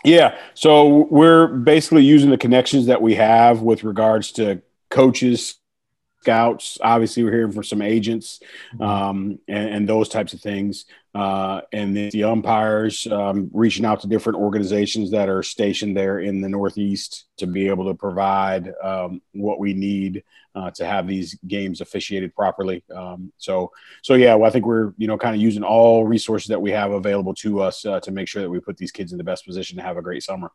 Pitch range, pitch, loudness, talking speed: 100-115 Hz, 105 Hz, -18 LUFS, 200 wpm